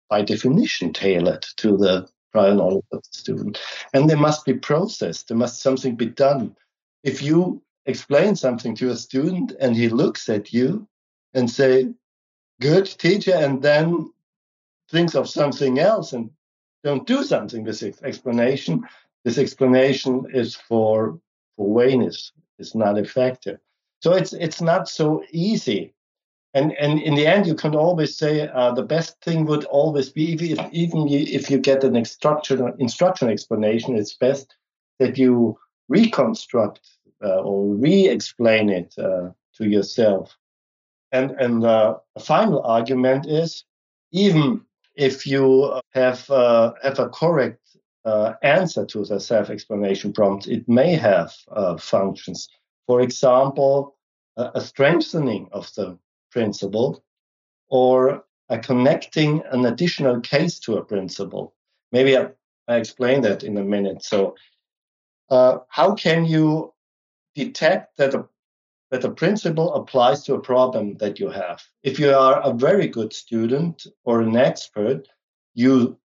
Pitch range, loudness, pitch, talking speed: 115-155 Hz, -20 LUFS, 130 Hz, 140 wpm